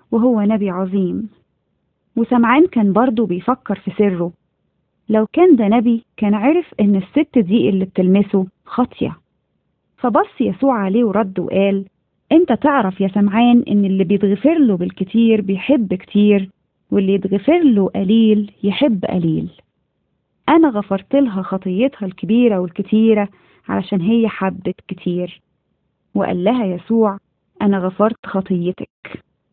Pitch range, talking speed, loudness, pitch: 195-235 Hz, 120 wpm, -16 LUFS, 205 Hz